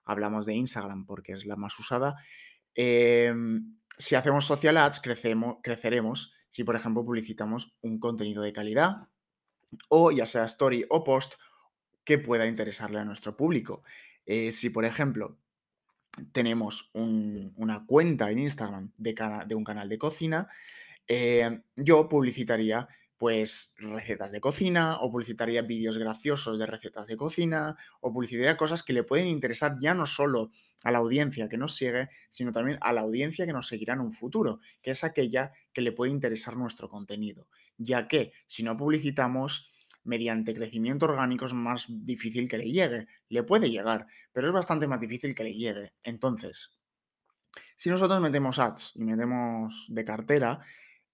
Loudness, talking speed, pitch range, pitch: -29 LUFS, 160 wpm, 110-135 Hz, 120 Hz